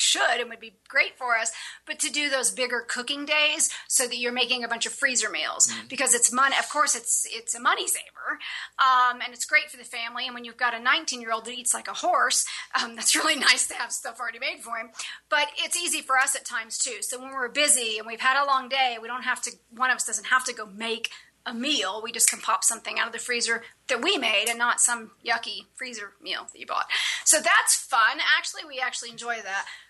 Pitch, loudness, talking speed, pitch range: 245 Hz, -24 LUFS, 250 wpm, 230-270 Hz